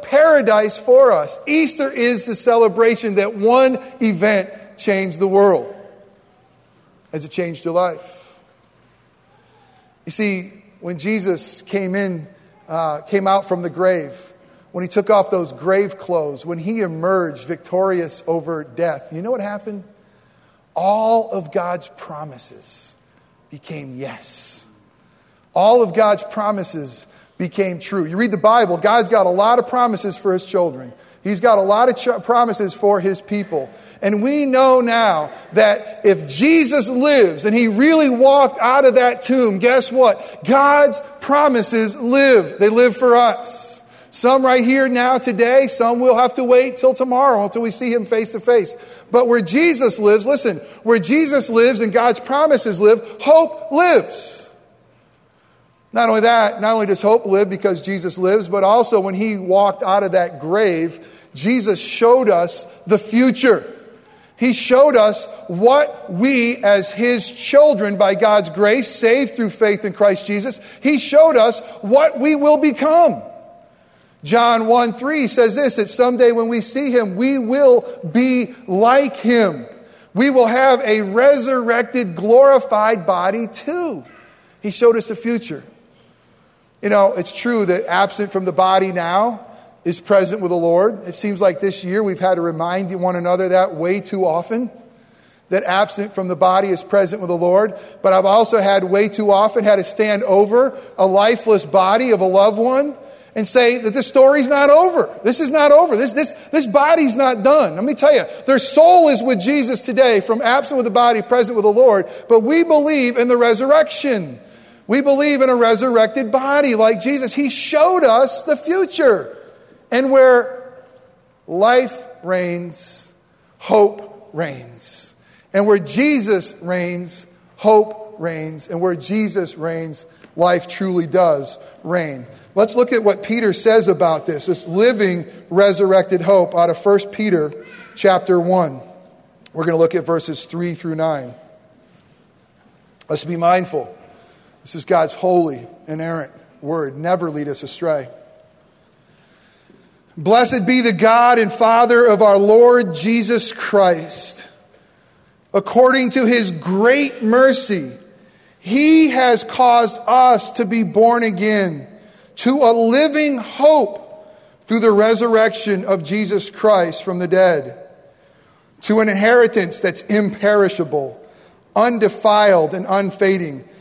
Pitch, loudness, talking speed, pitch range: 215 Hz, -15 LUFS, 150 wpm, 185-245 Hz